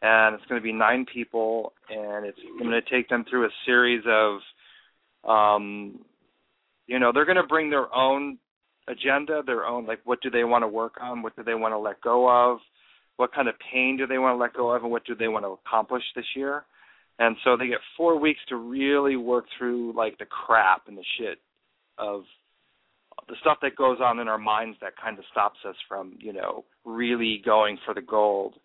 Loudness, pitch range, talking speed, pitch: -24 LUFS, 110-130 Hz, 215 wpm, 120 Hz